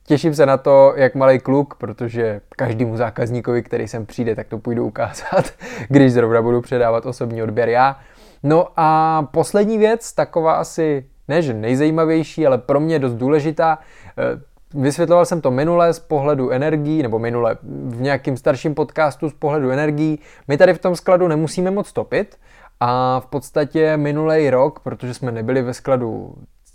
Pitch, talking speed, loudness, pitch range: 140 Hz, 160 wpm, -17 LUFS, 120-155 Hz